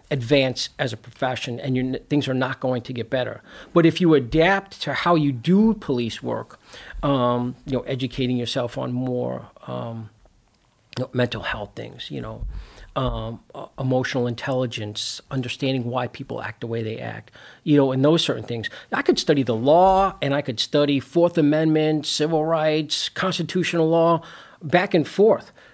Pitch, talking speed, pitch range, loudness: 135 Hz, 175 wpm, 120-155 Hz, -22 LUFS